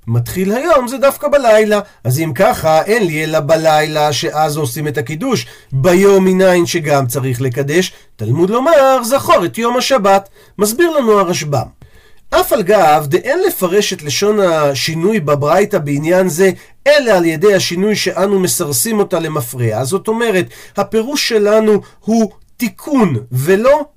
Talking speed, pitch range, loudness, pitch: 145 wpm, 155-220 Hz, -13 LUFS, 185 Hz